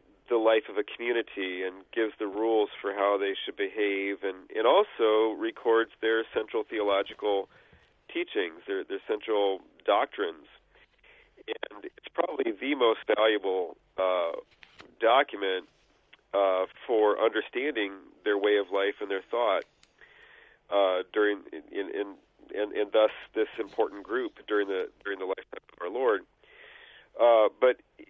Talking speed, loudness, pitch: 140 wpm, -28 LUFS, 350 Hz